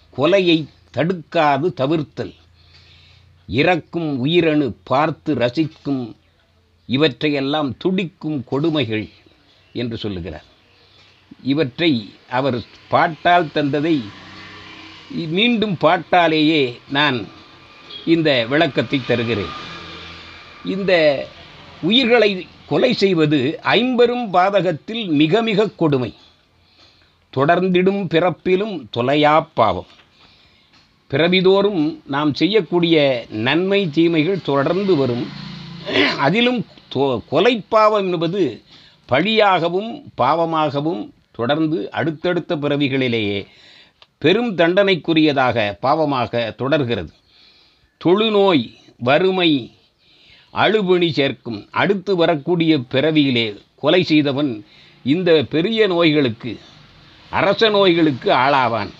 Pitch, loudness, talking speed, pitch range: 155 Hz, -17 LUFS, 70 wpm, 120-180 Hz